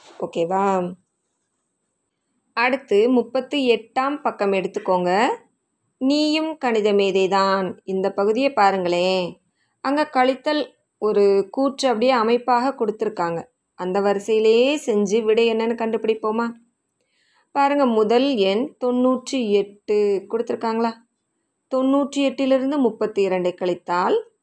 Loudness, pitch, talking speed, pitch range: -20 LUFS, 230 Hz, 90 wpm, 200-260 Hz